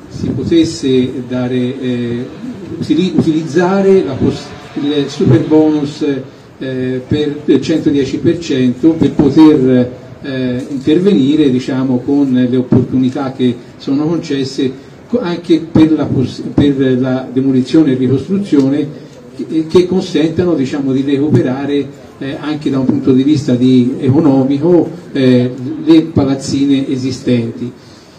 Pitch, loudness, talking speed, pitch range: 140 Hz, -13 LUFS, 110 wpm, 130-155 Hz